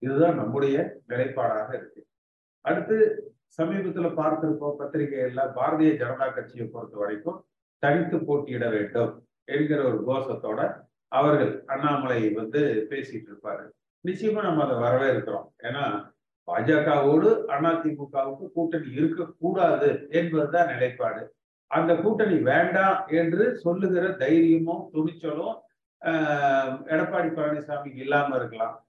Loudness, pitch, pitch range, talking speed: -25 LUFS, 155 Hz, 135-170 Hz, 100 wpm